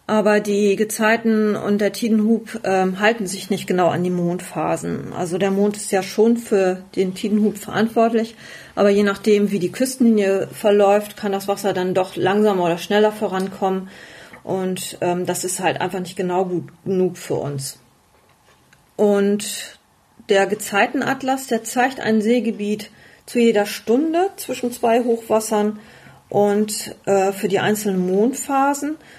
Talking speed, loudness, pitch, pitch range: 145 wpm, -19 LUFS, 205 Hz, 190-220 Hz